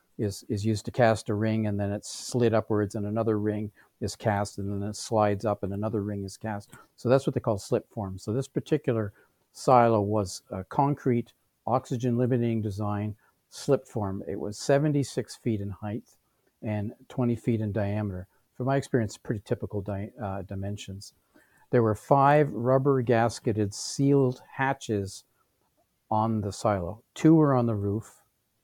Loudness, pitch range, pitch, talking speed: -28 LUFS, 105-125 Hz, 110 Hz, 170 wpm